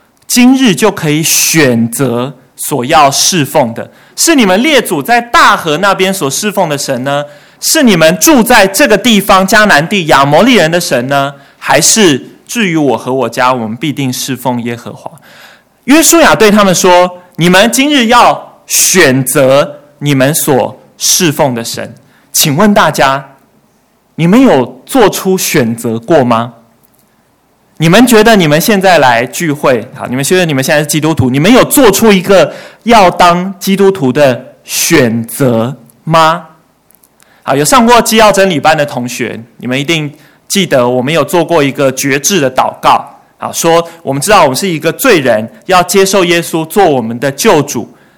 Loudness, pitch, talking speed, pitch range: -8 LUFS, 160 Hz, 240 characters per minute, 135-200 Hz